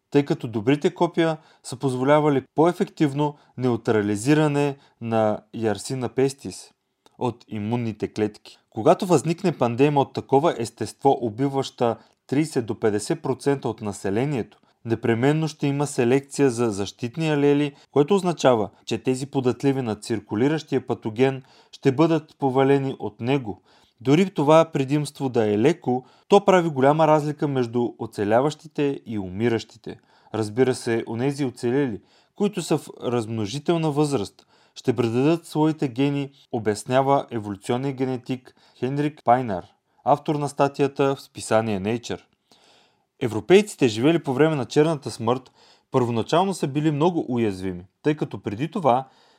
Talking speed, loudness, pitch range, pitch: 120 wpm, -23 LUFS, 115-150 Hz, 135 Hz